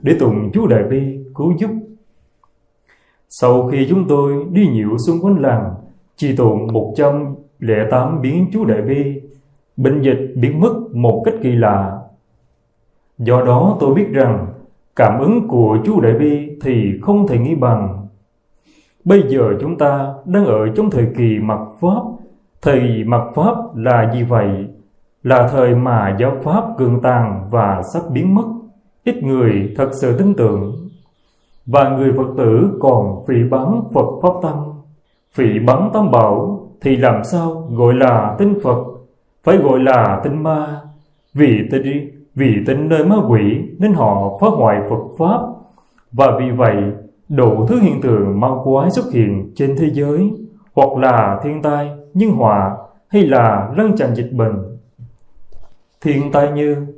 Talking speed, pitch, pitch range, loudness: 160 wpm, 135 Hz, 115-150 Hz, -15 LUFS